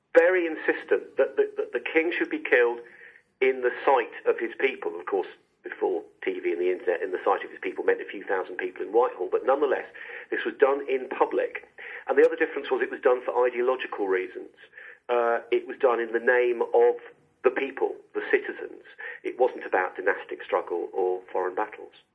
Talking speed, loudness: 200 wpm, -26 LUFS